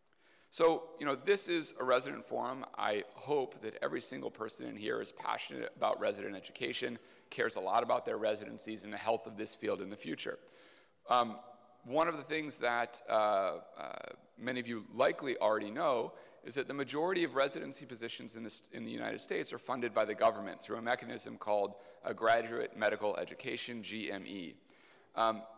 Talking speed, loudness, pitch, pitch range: 185 wpm, -36 LUFS, 120 Hz, 110-155 Hz